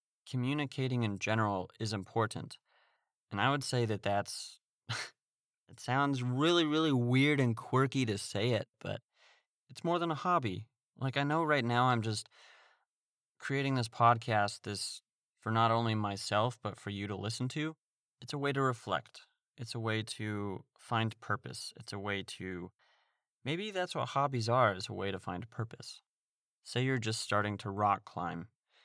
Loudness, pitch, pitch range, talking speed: -34 LUFS, 120 Hz, 105-135 Hz, 170 wpm